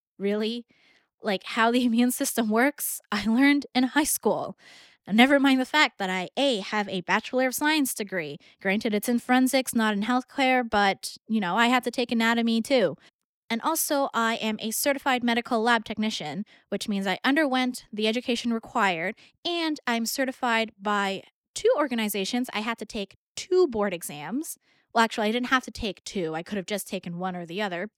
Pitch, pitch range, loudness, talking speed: 230 Hz, 205-255 Hz, -25 LUFS, 185 wpm